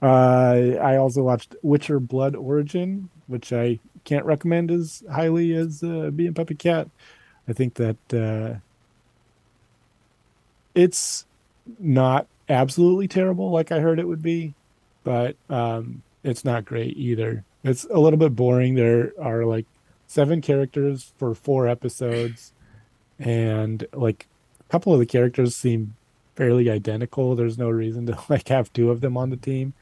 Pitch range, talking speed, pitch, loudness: 120-155 Hz, 145 wpm, 130 Hz, -22 LUFS